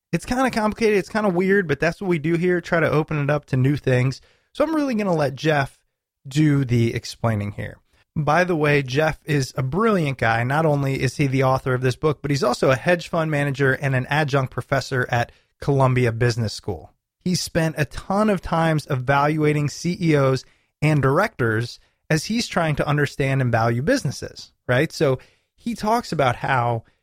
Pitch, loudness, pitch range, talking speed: 145 Hz, -21 LUFS, 130-165 Hz, 200 wpm